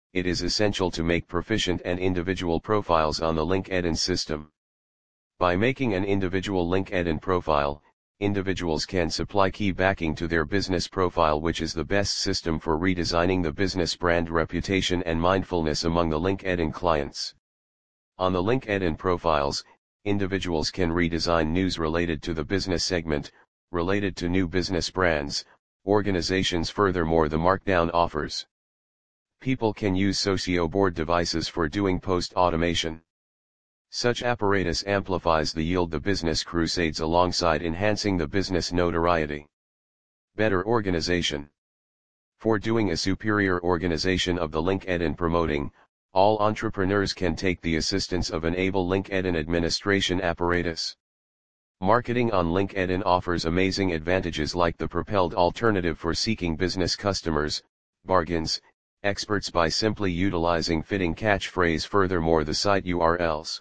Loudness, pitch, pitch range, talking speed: -25 LUFS, 90 Hz, 80-95 Hz, 130 wpm